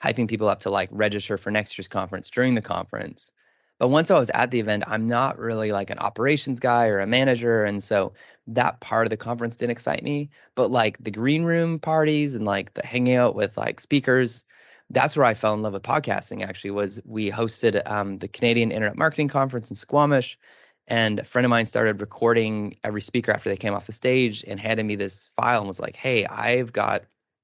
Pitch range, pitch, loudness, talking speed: 105-125 Hz, 115 Hz, -23 LUFS, 220 wpm